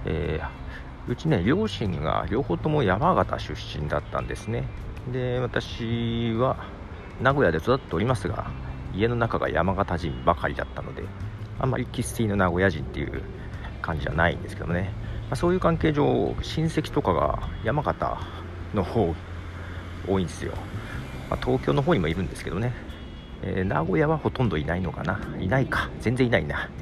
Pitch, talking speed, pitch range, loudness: 95 Hz, 330 characters per minute, 85-115 Hz, -26 LUFS